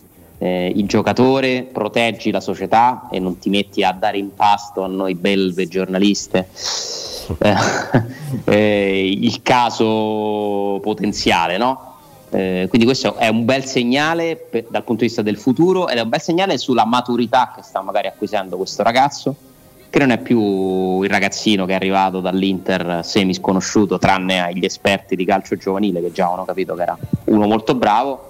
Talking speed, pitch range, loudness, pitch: 160 wpm, 95-120 Hz, -17 LUFS, 105 Hz